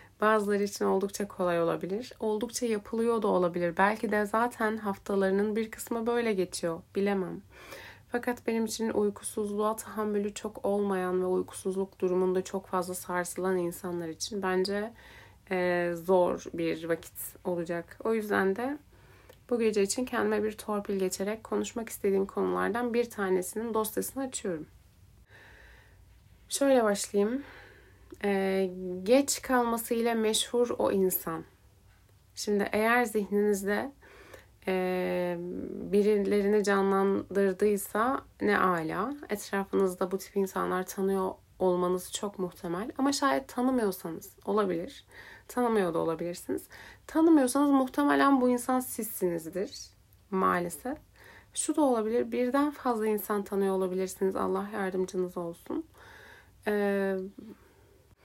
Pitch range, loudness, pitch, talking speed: 180-225 Hz, -30 LUFS, 200 Hz, 110 wpm